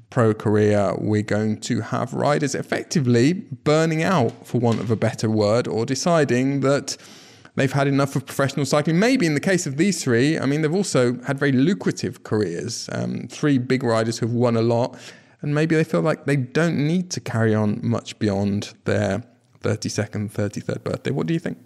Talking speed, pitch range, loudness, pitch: 195 wpm, 110-150 Hz, -21 LUFS, 125 Hz